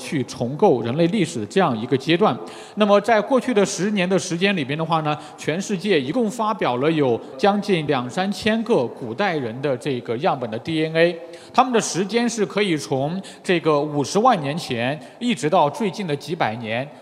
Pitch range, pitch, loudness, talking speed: 145-205 Hz, 170 Hz, -21 LUFS, 285 characters per minute